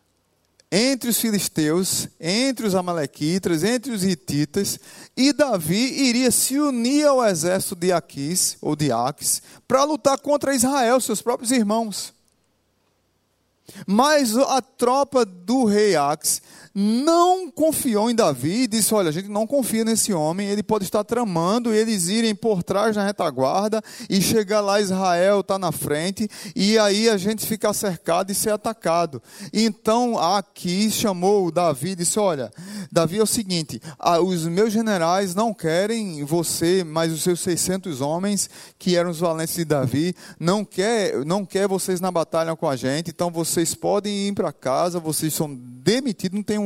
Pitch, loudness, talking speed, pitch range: 200 Hz, -21 LUFS, 160 wpm, 170-225 Hz